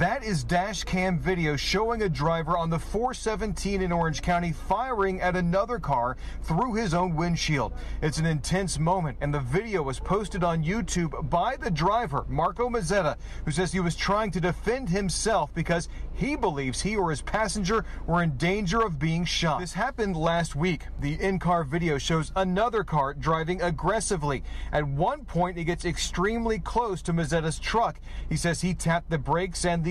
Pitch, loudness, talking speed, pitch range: 175 Hz, -27 LUFS, 180 wpm, 160-190 Hz